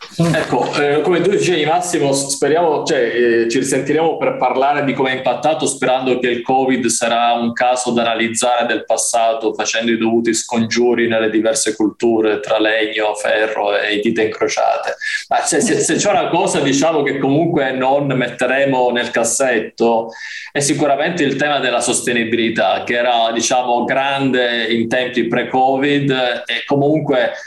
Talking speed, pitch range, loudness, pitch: 155 wpm, 115-140 Hz, -15 LUFS, 125 Hz